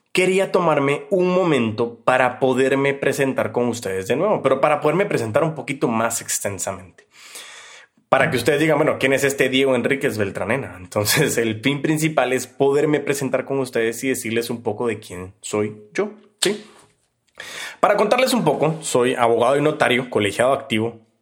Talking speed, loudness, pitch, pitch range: 165 wpm, -20 LUFS, 135 Hz, 115-150 Hz